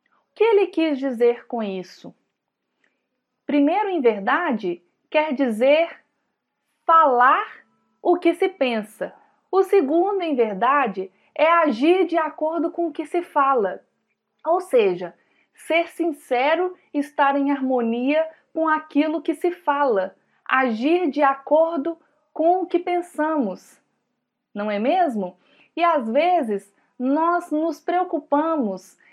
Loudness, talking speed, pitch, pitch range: -21 LUFS, 115 wpm, 310 Hz, 260-335 Hz